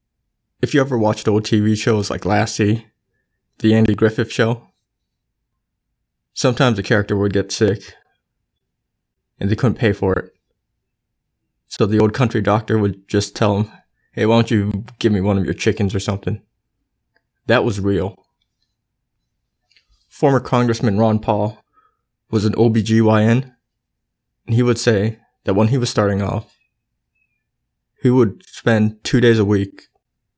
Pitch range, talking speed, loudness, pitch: 105-115 Hz, 145 wpm, -18 LUFS, 110 Hz